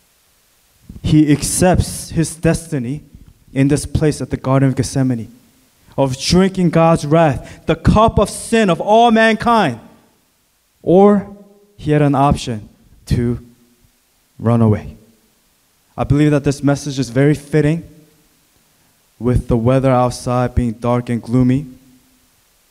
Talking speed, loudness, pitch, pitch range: 125 wpm, -15 LUFS, 140 Hz, 125-165 Hz